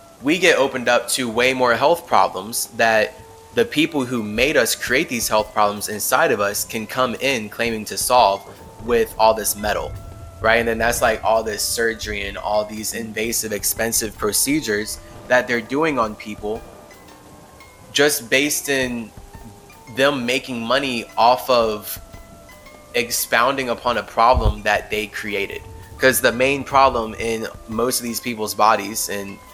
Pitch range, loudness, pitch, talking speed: 105-125 Hz, -19 LUFS, 110 Hz, 155 wpm